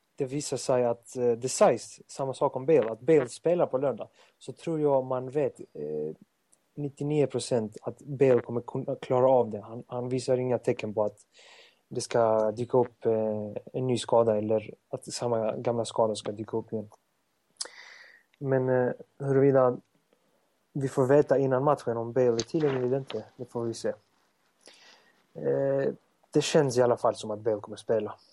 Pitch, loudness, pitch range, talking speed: 125 Hz, -28 LUFS, 115-135 Hz, 175 wpm